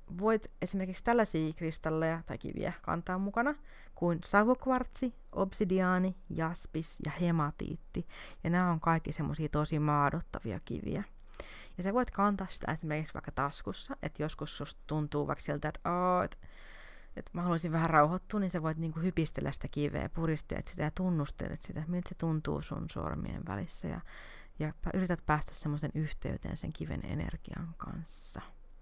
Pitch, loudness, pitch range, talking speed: 165 Hz, -35 LUFS, 155-185 Hz, 150 wpm